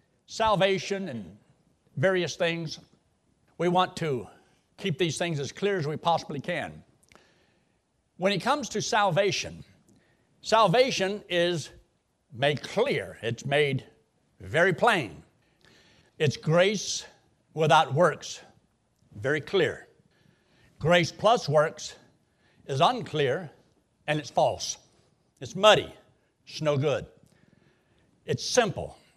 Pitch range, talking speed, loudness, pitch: 150-195 Hz, 105 wpm, -26 LUFS, 175 Hz